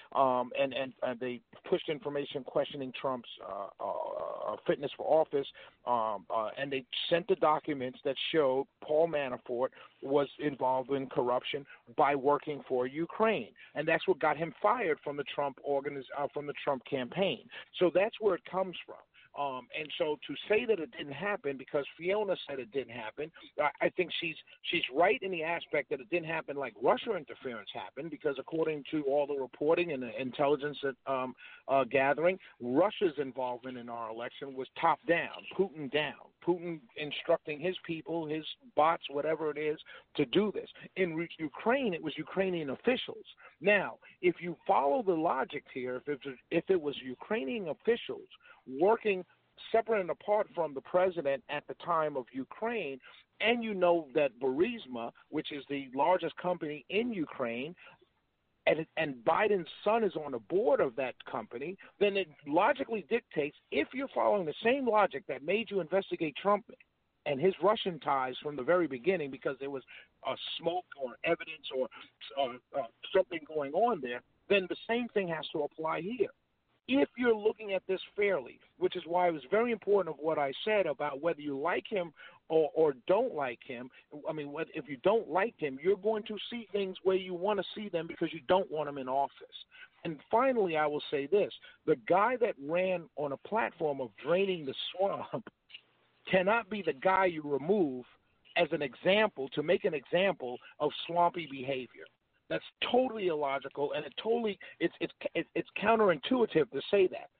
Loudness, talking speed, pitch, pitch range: -33 LUFS, 180 wpm, 165 Hz, 140-200 Hz